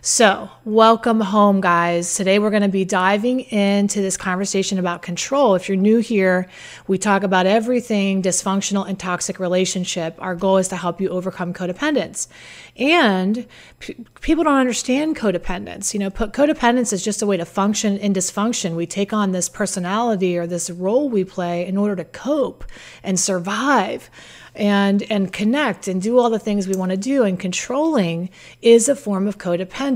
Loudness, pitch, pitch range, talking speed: -19 LUFS, 200 Hz, 185-225 Hz, 175 wpm